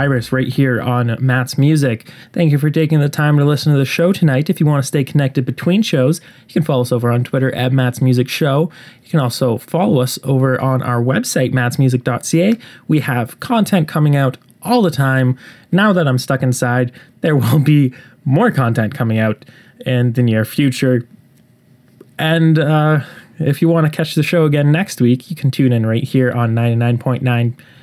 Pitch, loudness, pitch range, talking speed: 135 Hz, -15 LUFS, 125-155 Hz, 195 wpm